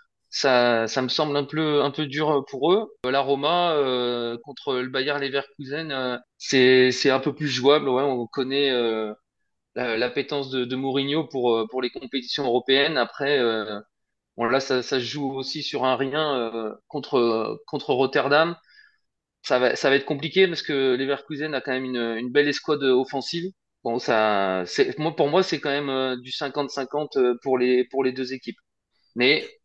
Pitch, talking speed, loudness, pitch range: 135 Hz, 180 wpm, -23 LUFS, 125-145 Hz